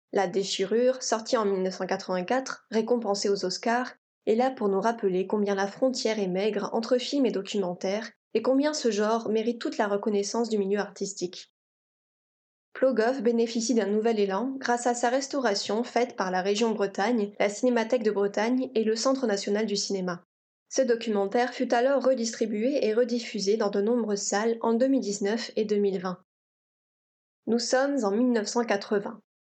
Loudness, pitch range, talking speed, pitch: -27 LUFS, 200-245 Hz, 155 wpm, 220 Hz